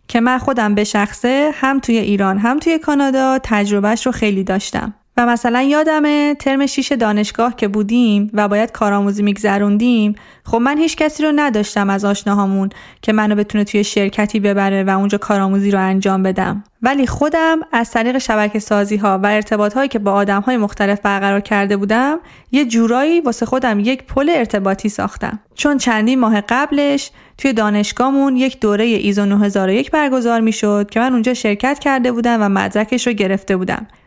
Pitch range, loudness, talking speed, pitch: 205-260 Hz, -15 LUFS, 170 wpm, 220 Hz